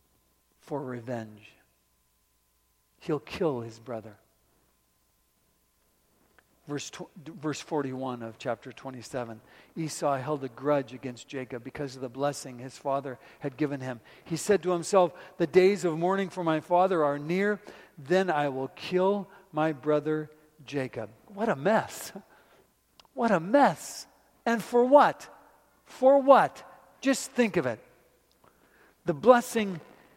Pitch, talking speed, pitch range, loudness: 145 Hz, 130 wpm, 125-180 Hz, -28 LUFS